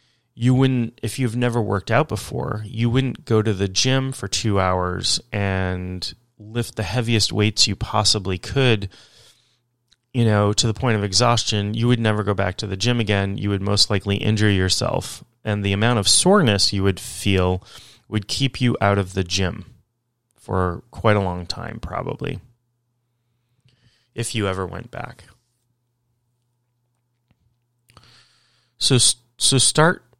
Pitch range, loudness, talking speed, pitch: 100-120 Hz, -20 LUFS, 150 wpm, 115 Hz